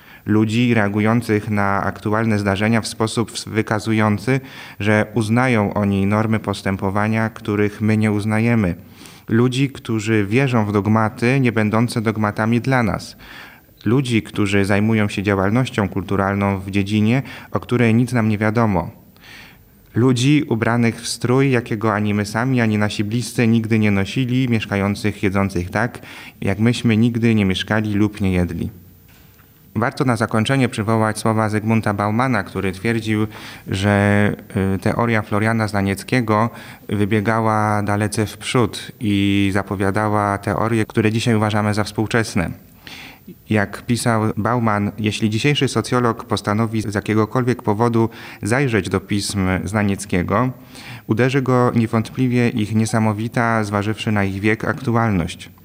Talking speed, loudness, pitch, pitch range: 125 wpm, -19 LUFS, 110 Hz, 105-115 Hz